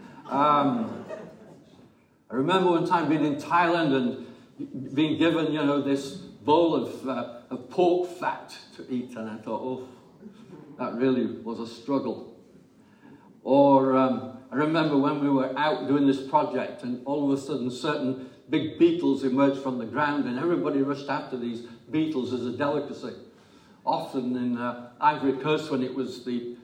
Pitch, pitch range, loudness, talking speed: 135 Hz, 125-150 Hz, -26 LUFS, 160 wpm